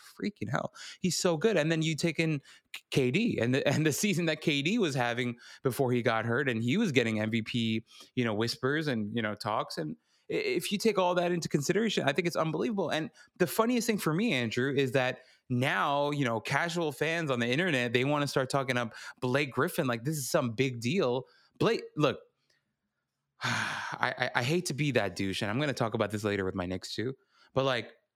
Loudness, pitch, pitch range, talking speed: -30 LUFS, 140 Hz, 120-170 Hz, 220 wpm